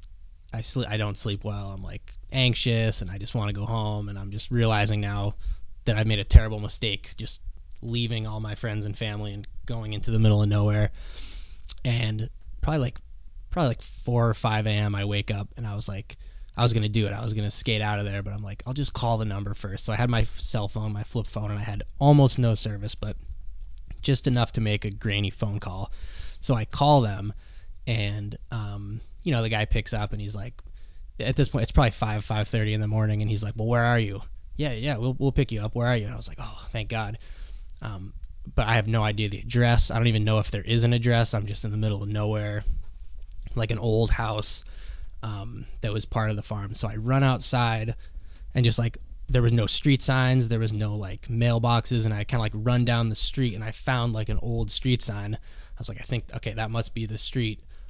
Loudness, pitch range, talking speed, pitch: -26 LUFS, 100-115 Hz, 245 wpm, 110 Hz